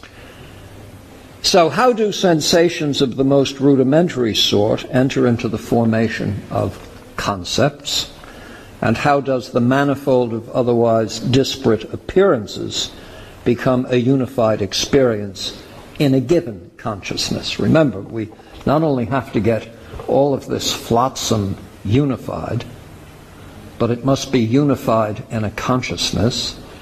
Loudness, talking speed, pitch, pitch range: -17 LUFS, 115 wpm, 120 Hz, 105-135 Hz